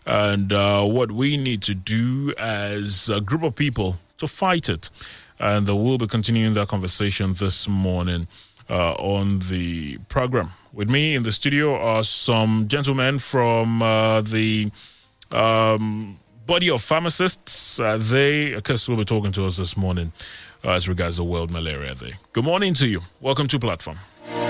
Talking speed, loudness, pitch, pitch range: 165 wpm, -21 LUFS, 110 Hz, 100-125 Hz